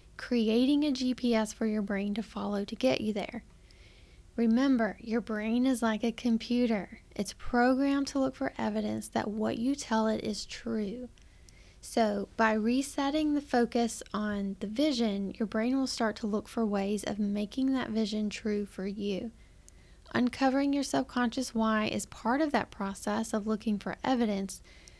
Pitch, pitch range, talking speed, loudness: 225 Hz, 210-250 Hz, 165 wpm, -31 LUFS